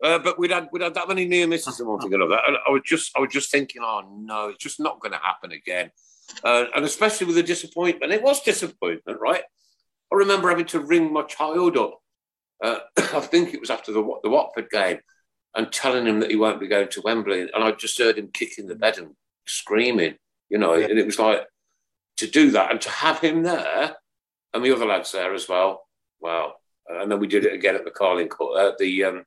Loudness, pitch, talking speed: -22 LUFS, 165 Hz, 230 wpm